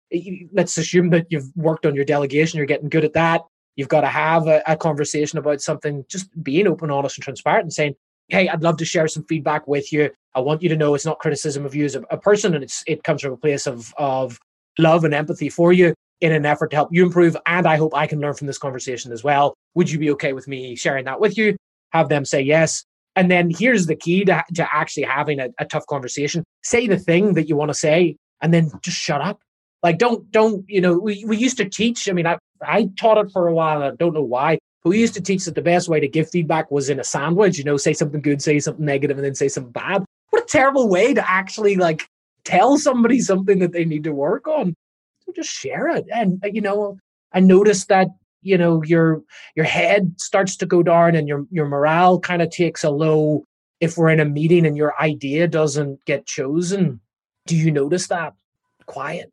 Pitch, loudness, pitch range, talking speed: 160 Hz, -19 LUFS, 150-180 Hz, 240 wpm